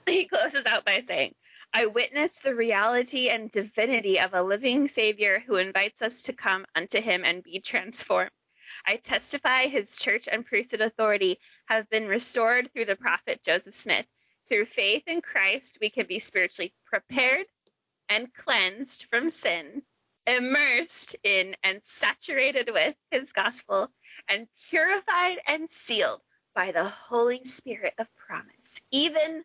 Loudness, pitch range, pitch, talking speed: -25 LUFS, 210-310 Hz, 245 Hz, 145 wpm